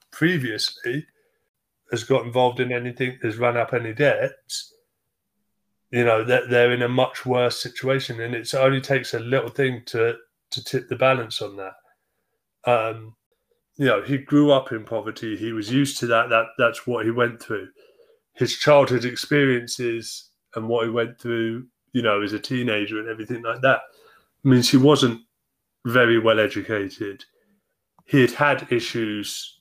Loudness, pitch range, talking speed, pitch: -22 LUFS, 115-135 Hz, 165 wpm, 120 Hz